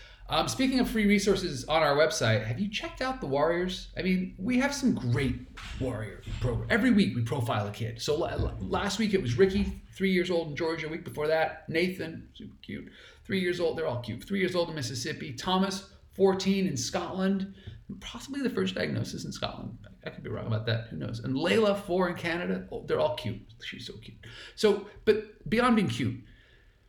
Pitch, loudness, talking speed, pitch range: 170 Hz, -29 LUFS, 205 wpm, 125-195 Hz